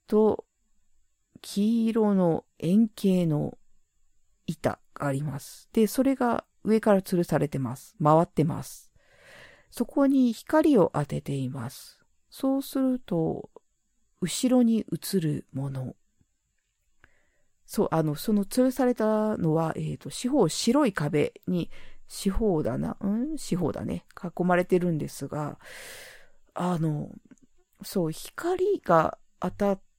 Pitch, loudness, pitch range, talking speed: 195 Hz, -27 LUFS, 155-235 Hz, 210 characters per minute